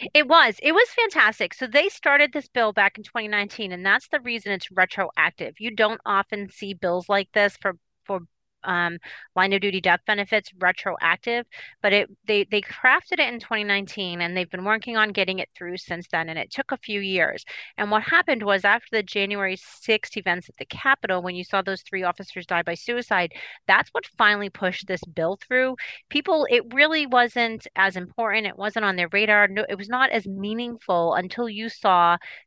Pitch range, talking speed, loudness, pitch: 185-235 Hz, 190 wpm, -22 LUFS, 205 Hz